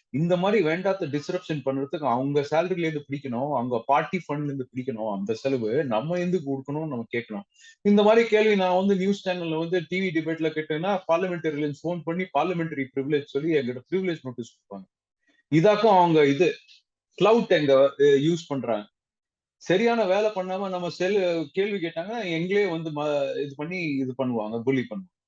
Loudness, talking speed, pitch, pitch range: -25 LUFS, 140 wpm, 160 Hz, 140-185 Hz